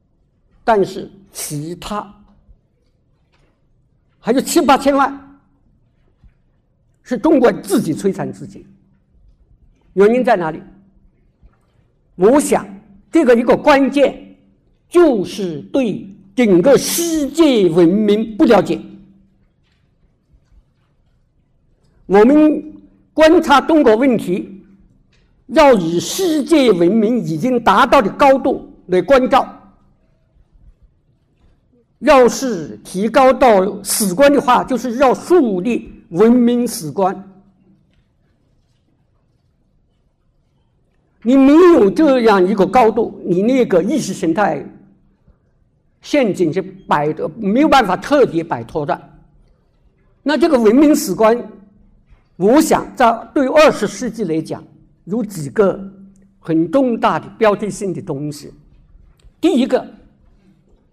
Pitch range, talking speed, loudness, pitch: 185-270 Hz, 145 characters per minute, -14 LUFS, 215 Hz